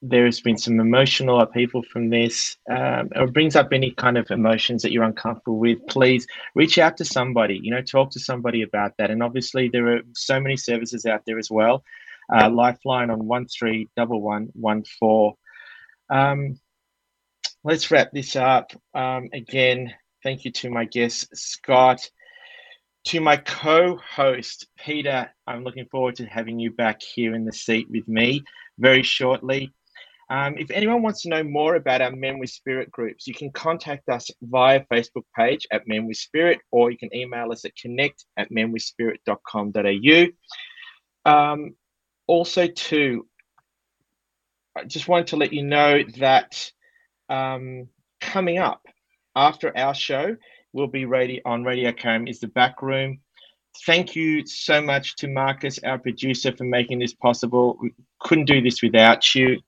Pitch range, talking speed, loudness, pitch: 120-140 Hz, 160 wpm, -21 LUFS, 130 Hz